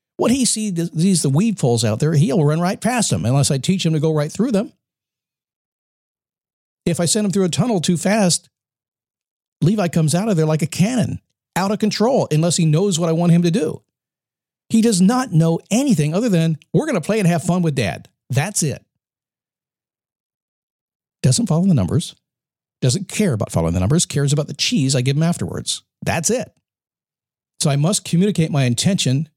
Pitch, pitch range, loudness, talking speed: 165 Hz, 145-190 Hz, -18 LUFS, 195 wpm